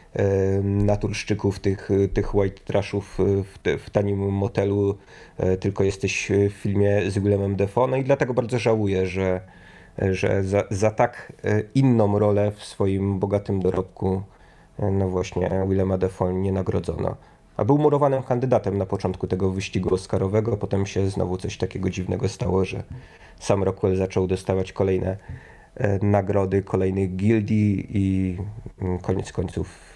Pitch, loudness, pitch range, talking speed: 100 Hz, -23 LUFS, 95-105 Hz, 135 wpm